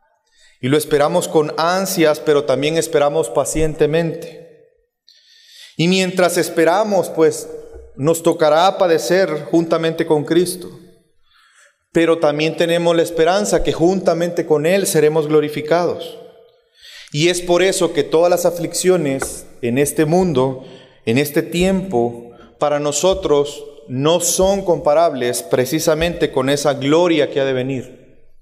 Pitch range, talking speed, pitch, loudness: 145-180 Hz, 120 wpm, 165 Hz, -16 LUFS